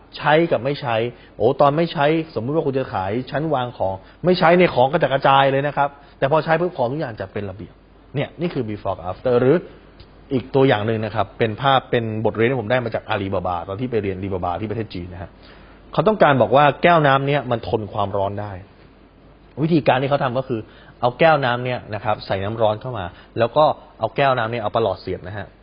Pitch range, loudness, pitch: 105-140 Hz, -20 LUFS, 120 Hz